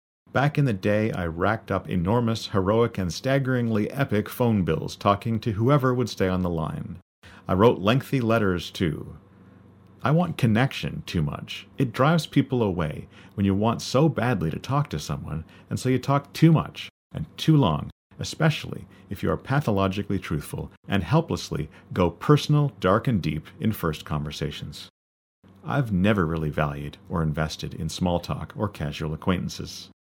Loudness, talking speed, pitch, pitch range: -25 LUFS, 165 wpm, 100 Hz, 90-130 Hz